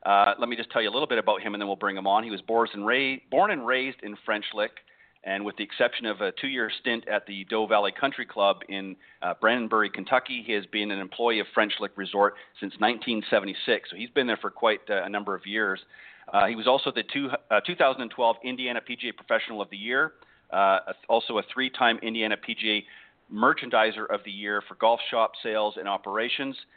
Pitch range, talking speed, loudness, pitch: 100-120 Hz, 220 wpm, -26 LUFS, 110 Hz